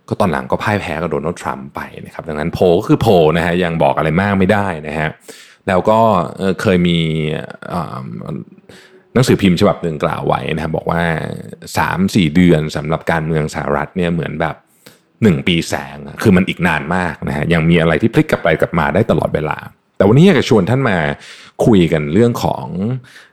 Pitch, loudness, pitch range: 85 Hz, -15 LUFS, 75-95 Hz